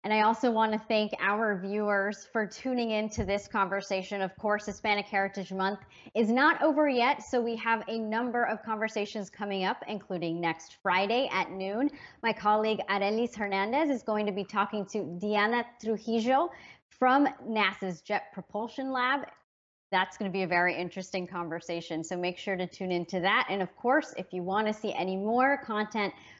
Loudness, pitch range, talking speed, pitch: -30 LUFS, 190-225 Hz, 180 wpm, 210 Hz